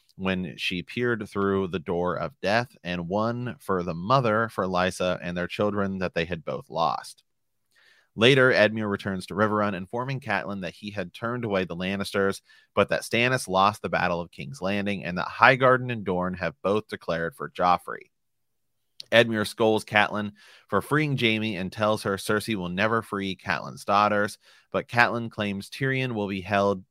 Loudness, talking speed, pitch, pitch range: -25 LUFS, 175 wpm, 100 Hz, 95-115 Hz